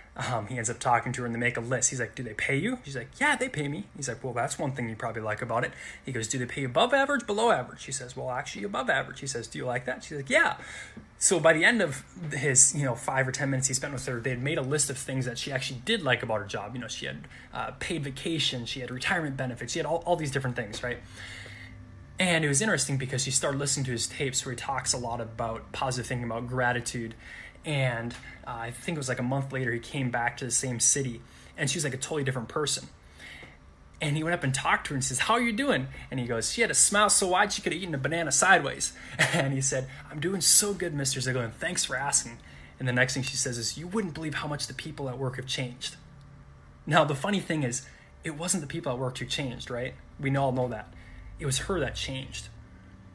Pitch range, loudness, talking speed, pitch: 120-150 Hz, -28 LUFS, 270 wpm, 130 Hz